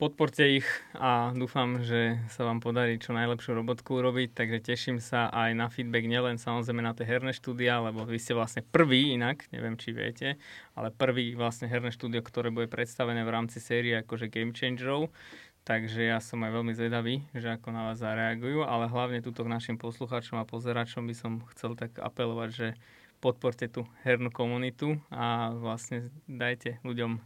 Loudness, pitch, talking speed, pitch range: -31 LUFS, 120 Hz, 175 wpm, 115-125 Hz